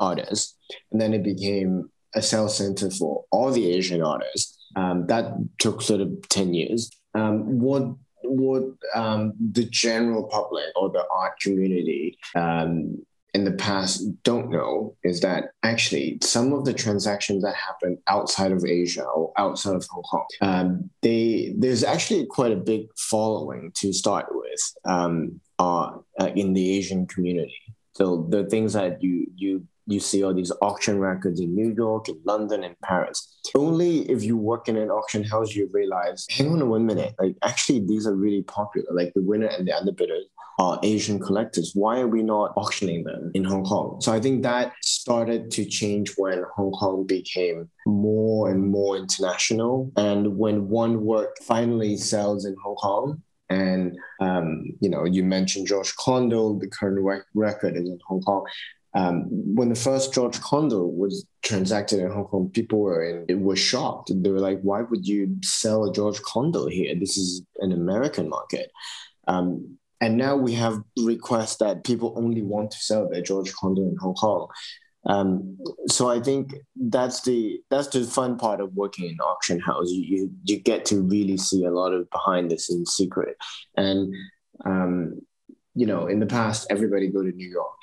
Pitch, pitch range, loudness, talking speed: 105 Hz, 95-115 Hz, -24 LUFS, 180 wpm